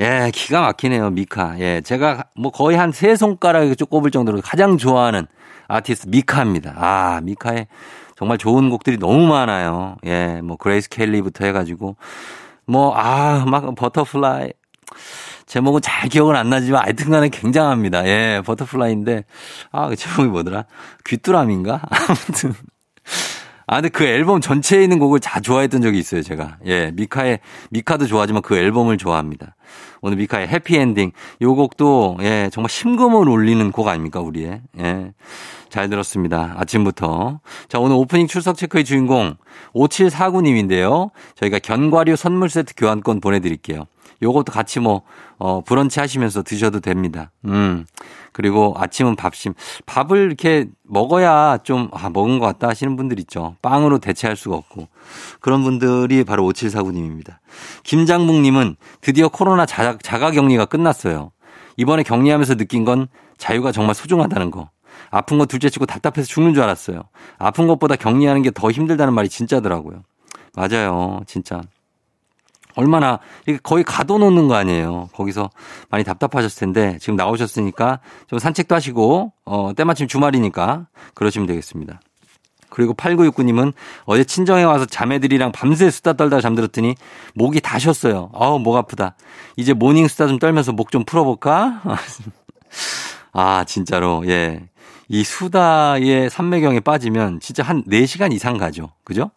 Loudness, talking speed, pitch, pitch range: -17 LUFS, 335 characters per minute, 120 Hz, 100-145 Hz